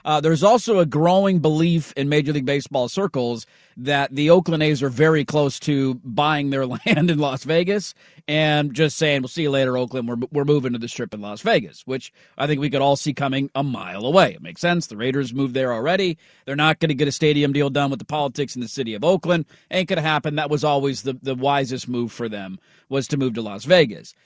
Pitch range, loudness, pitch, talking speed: 130-155 Hz, -21 LUFS, 145 Hz, 240 wpm